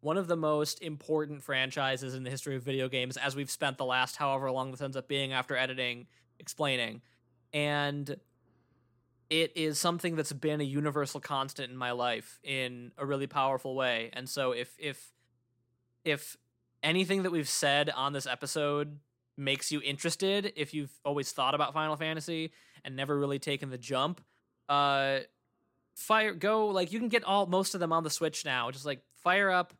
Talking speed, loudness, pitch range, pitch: 180 wpm, -32 LUFS, 130-155 Hz, 140 Hz